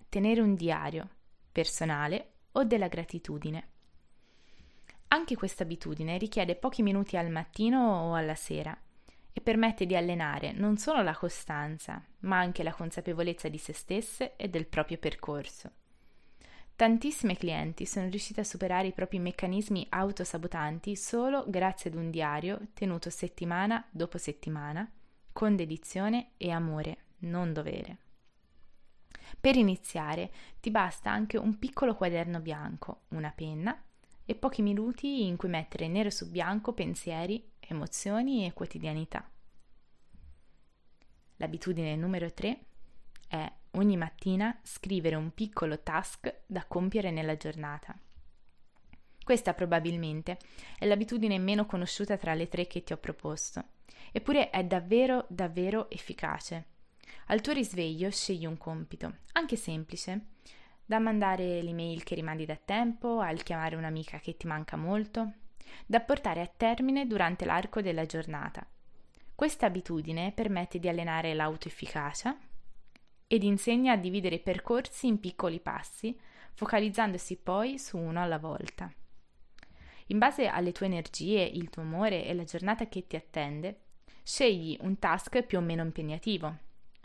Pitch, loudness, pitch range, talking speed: 185 Hz, -33 LUFS, 165-215 Hz, 130 wpm